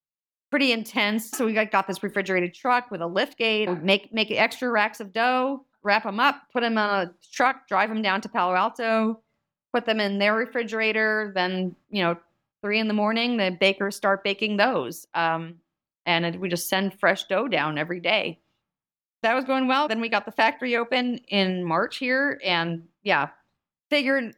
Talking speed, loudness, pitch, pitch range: 190 wpm, -24 LUFS, 210 Hz, 190-235 Hz